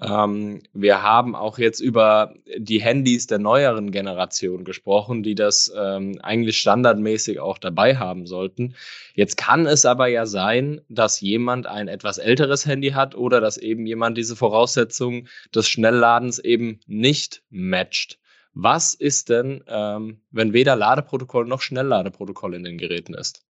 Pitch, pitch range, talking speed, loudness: 110 Hz, 105-125 Hz, 140 wpm, -20 LUFS